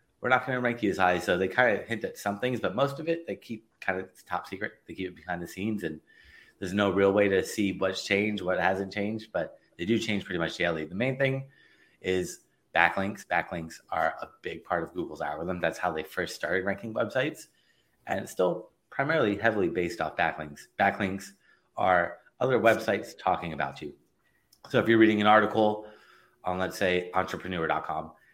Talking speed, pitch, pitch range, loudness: 205 wpm, 100 Hz, 95-110 Hz, -28 LUFS